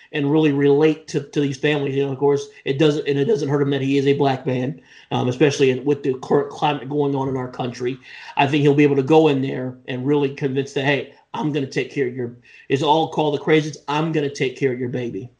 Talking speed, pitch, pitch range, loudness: 275 wpm, 140 Hz, 135-150 Hz, -20 LUFS